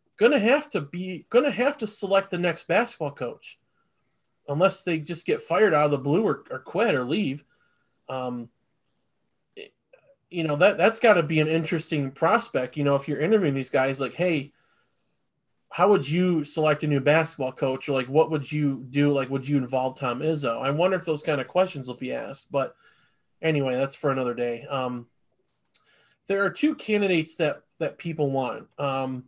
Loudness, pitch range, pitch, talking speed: -25 LUFS, 135-180 Hz, 150 Hz, 190 wpm